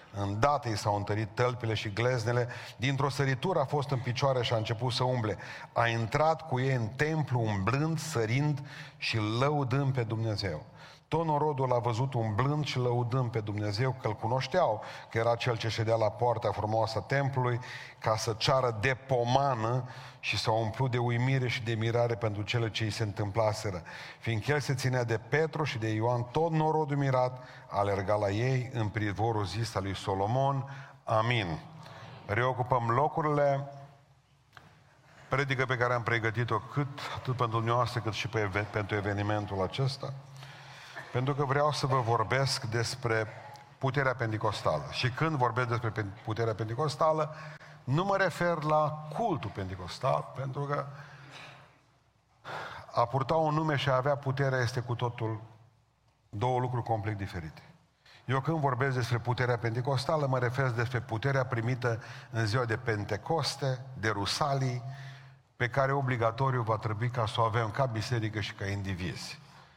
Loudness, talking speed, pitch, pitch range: -31 LUFS, 155 wpm, 125 Hz, 115-140 Hz